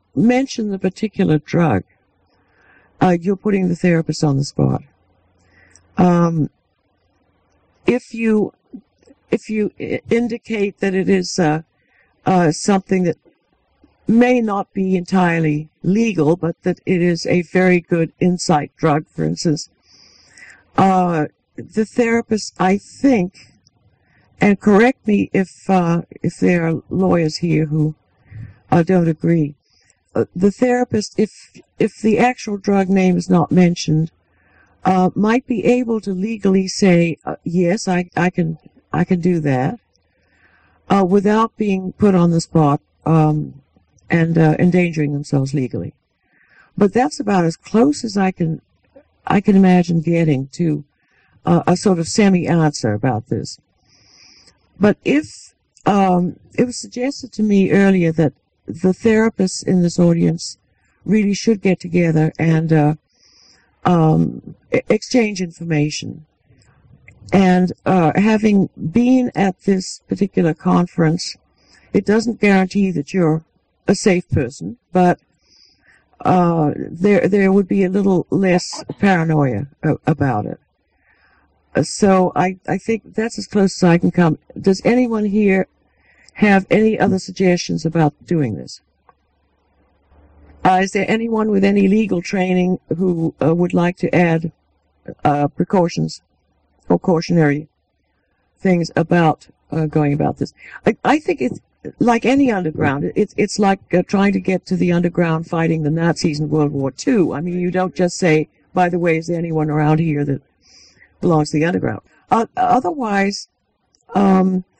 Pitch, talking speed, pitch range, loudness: 175 Hz, 140 wpm, 155-195 Hz, -17 LUFS